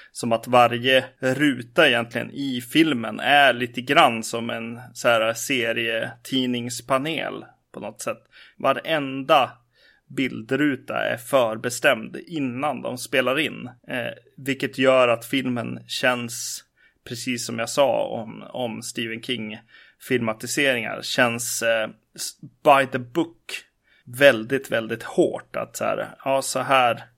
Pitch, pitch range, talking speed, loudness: 125 Hz, 115-135 Hz, 120 wpm, -22 LUFS